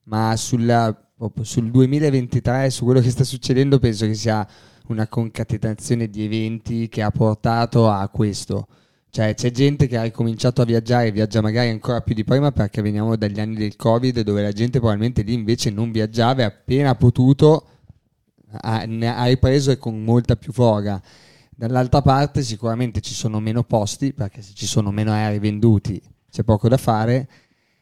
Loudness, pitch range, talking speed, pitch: -19 LUFS, 110-125 Hz, 170 wpm, 115 Hz